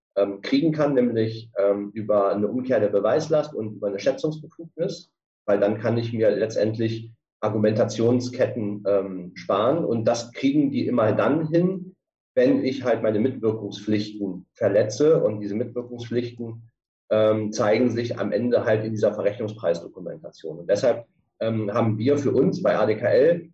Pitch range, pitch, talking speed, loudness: 105-130 Hz, 115 Hz, 135 wpm, -23 LUFS